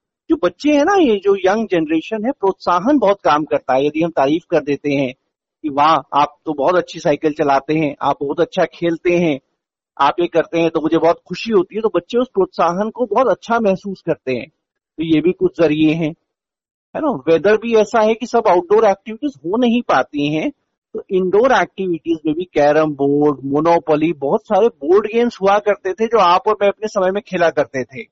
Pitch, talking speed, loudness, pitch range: 175 Hz, 210 wpm, -16 LUFS, 155-210 Hz